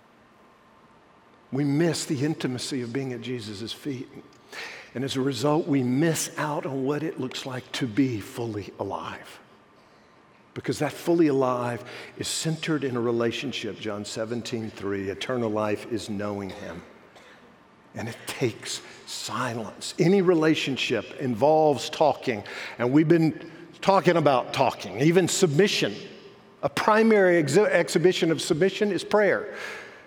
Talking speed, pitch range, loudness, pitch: 130 wpm, 120-170 Hz, -25 LUFS, 145 Hz